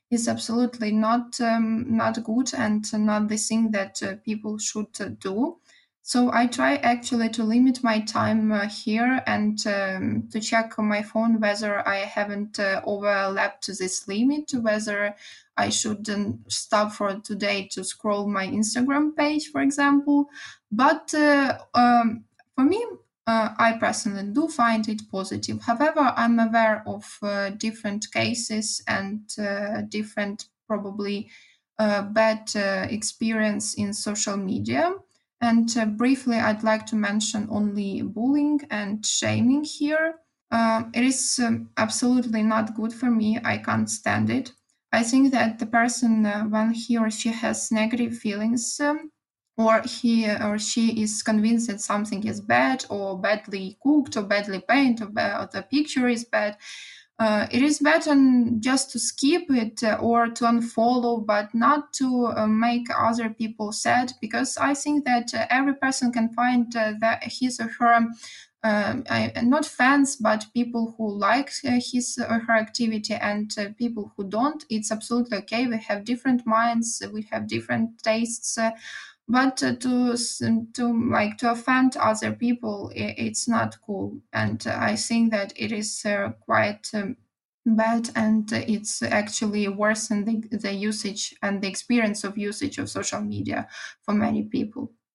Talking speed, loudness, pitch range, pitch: 155 wpm, -24 LUFS, 210-245 Hz, 225 Hz